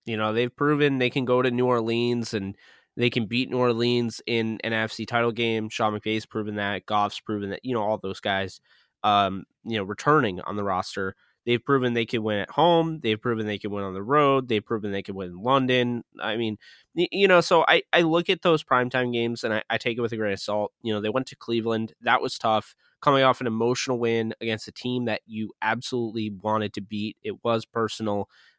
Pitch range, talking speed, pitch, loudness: 105-125 Hz, 230 wpm, 115 Hz, -25 LUFS